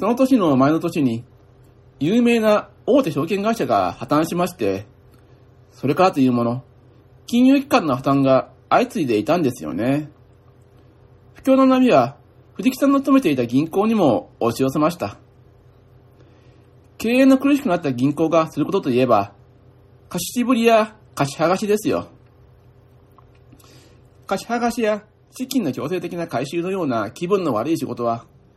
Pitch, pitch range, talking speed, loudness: 135 Hz, 125-200 Hz, 290 characters per minute, -19 LUFS